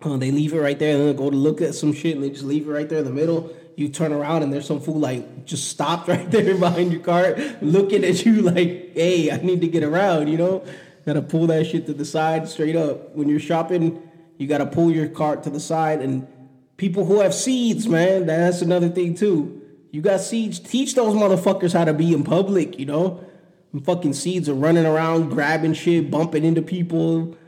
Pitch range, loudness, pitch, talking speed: 150-180 Hz, -20 LUFS, 165 Hz, 230 wpm